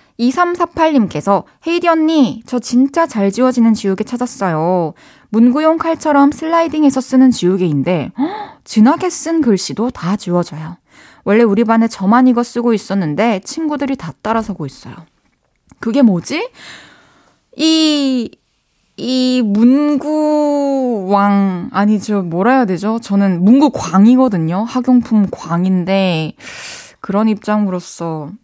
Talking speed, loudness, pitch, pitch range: 255 characters per minute, -14 LUFS, 230 Hz, 195-275 Hz